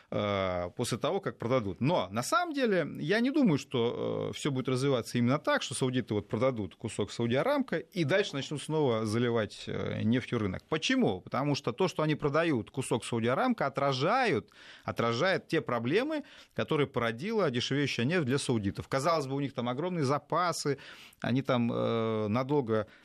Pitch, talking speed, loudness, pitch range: 135 Hz, 155 wpm, -31 LUFS, 115-160 Hz